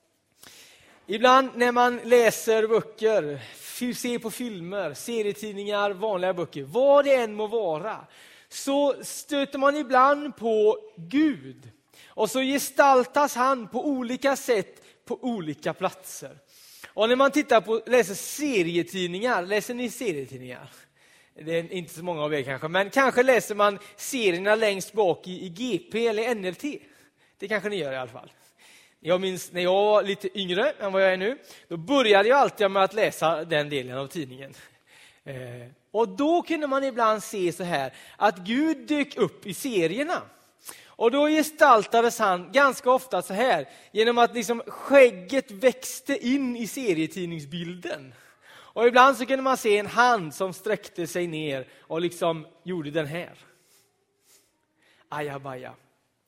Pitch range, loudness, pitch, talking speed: 175-255 Hz, -24 LUFS, 215 Hz, 150 wpm